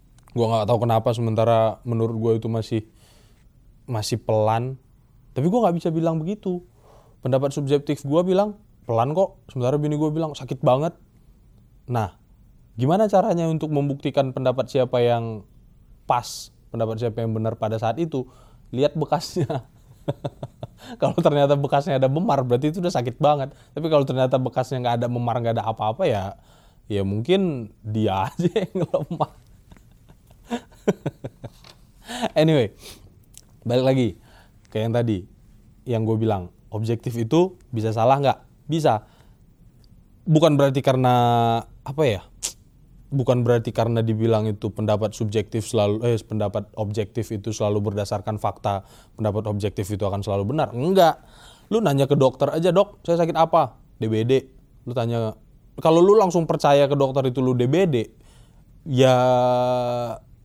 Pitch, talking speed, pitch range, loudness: 120 Hz, 135 wpm, 110-145 Hz, -22 LUFS